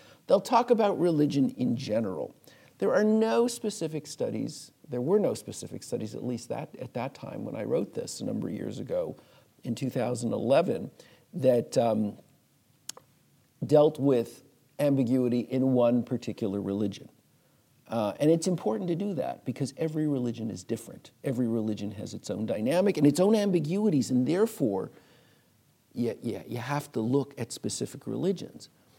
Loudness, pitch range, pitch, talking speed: -29 LUFS, 120-160 Hz, 135 Hz, 155 wpm